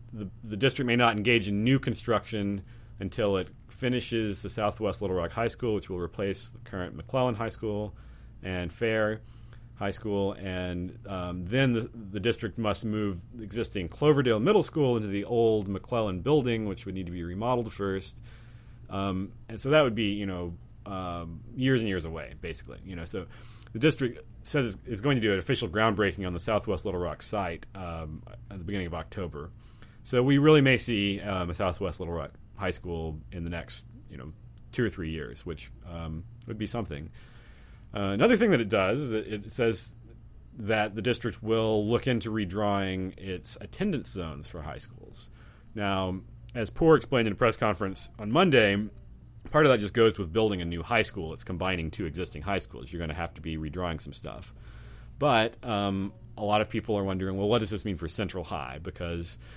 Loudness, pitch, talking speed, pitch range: -29 LUFS, 105 Hz, 195 wpm, 95-115 Hz